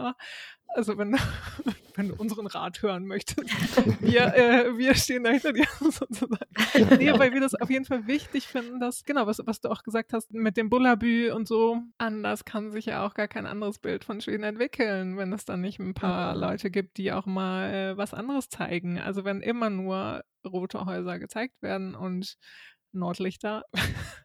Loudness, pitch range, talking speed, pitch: -27 LUFS, 195-245 Hz, 185 wpm, 220 Hz